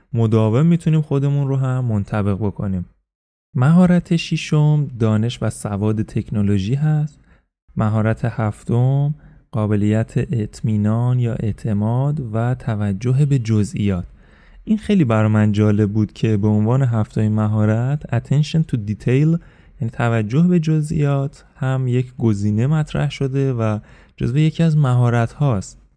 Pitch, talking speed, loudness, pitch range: 120 Hz, 125 wpm, -19 LUFS, 110-145 Hz